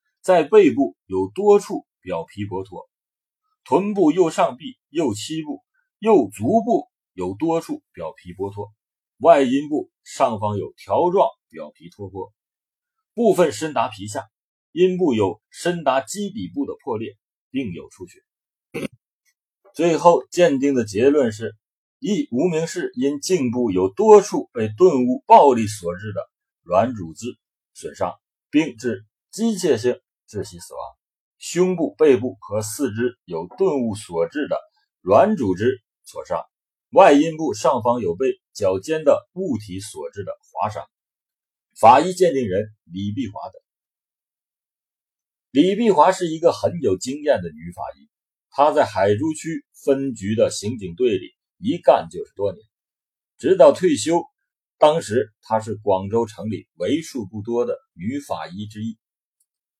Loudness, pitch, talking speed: -20 LUFS, 165 Hz, 200 characters per minute